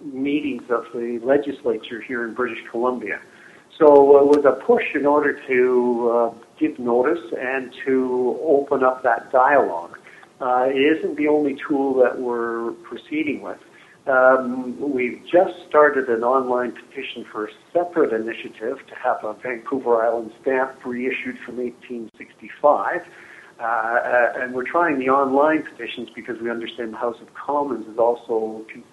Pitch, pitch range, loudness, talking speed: 125 Hz, 120-140 Hz, -20 LUFS, 145 wpm